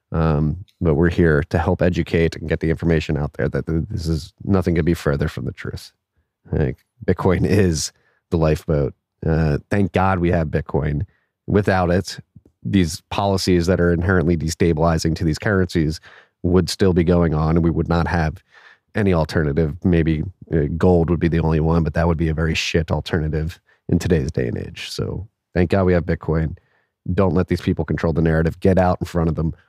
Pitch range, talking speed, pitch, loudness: 80-95 Hz, 190 wpm, 85 Hz, -20 LUFS